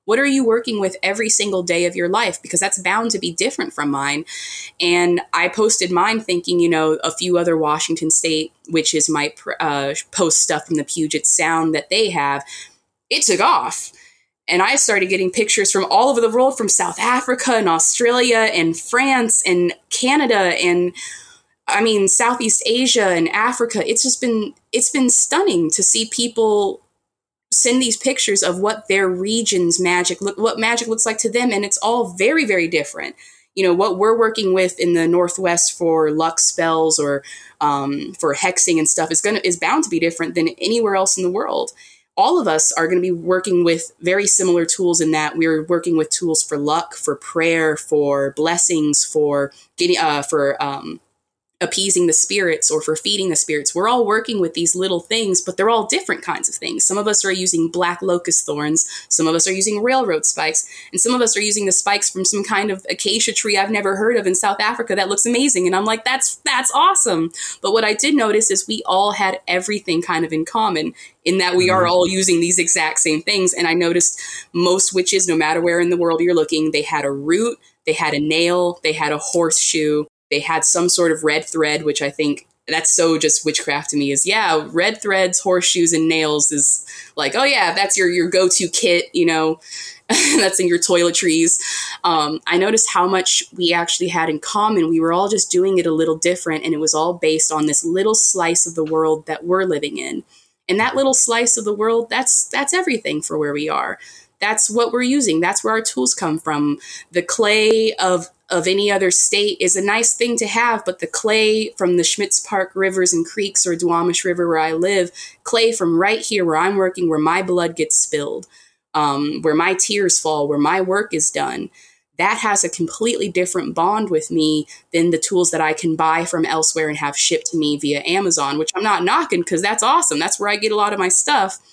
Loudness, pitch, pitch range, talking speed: -16 LUFS, 180 Hz, 165-215 Hz, 215 wpm